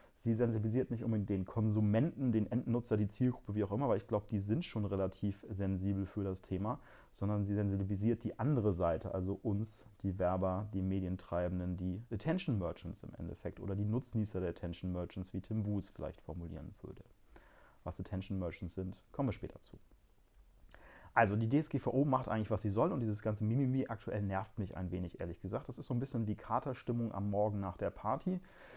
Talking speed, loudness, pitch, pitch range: 195 wpm, -37 LUFS, 105 Hz, 95-115 Hz